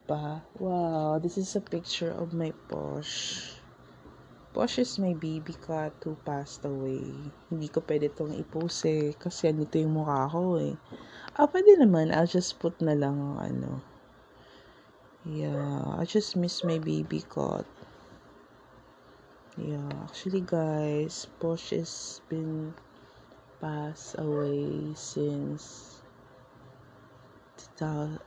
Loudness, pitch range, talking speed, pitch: -30 LUFS, 130-165 Hz, 115 wpm, 155 Hz